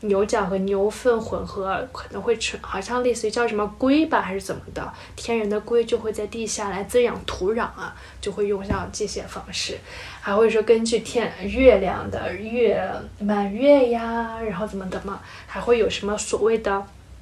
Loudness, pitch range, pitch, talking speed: -23 LUFS, 200-235 Hz, 220 Hz, 265 characters per minute